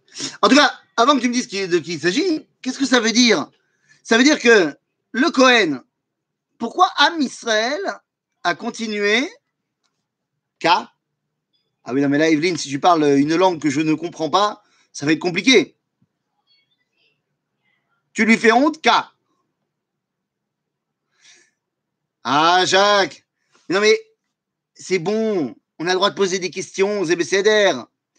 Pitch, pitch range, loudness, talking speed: 215 Hz, 185-265 Hz, -17 LUFS, 150 wpm